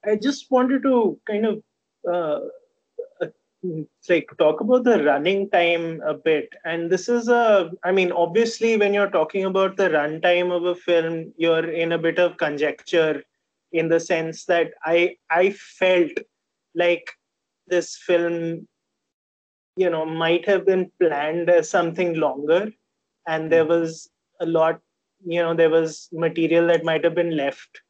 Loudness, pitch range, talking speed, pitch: -21 LUFS, 165-195 Hz, 155 wpm, 170 Hz